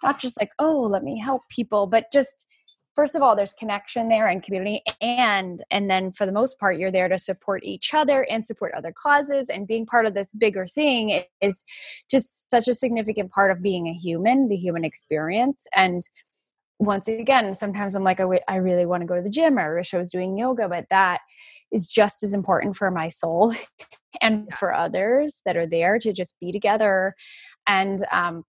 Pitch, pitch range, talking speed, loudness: 205 Hz, 190-250 Hz, 205 wpm, -22 LUFS